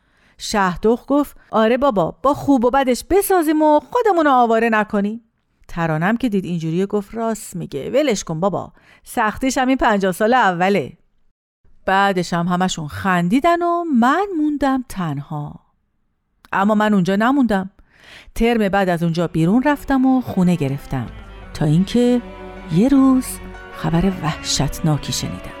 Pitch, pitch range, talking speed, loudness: 205 Hz, 170-260 Hz, 135 wpm, -18 LUFS